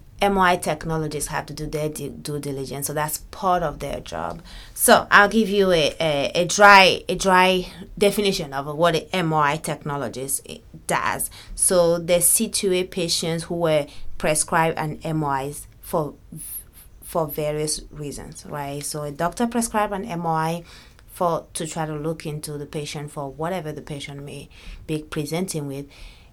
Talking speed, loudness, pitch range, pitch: 155 wpm, -21 LUFS, 145-175 Hz, 155 Hz